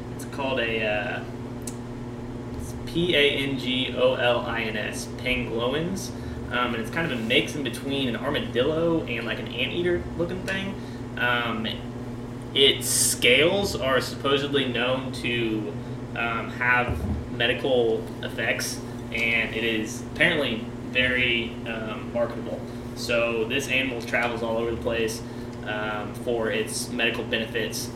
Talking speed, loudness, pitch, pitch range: 130 wpm, -25 LUFS, 120 Hz, 115-125 Hz